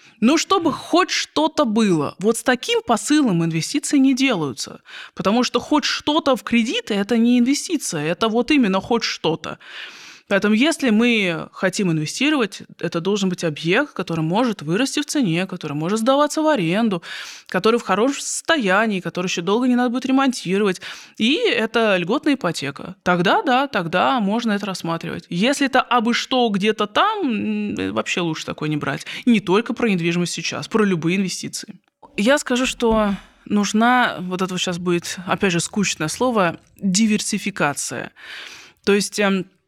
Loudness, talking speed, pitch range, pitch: -19 LUFS, 155 wpm, 185-255 Hz, 215 Hz